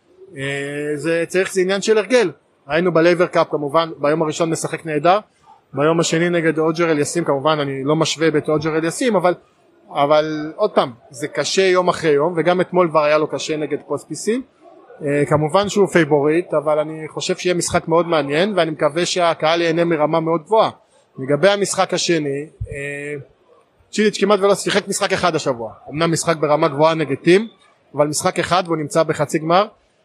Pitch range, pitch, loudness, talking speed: 150-180 Hz, 165 Hz, -18 LUFS, 170 wpm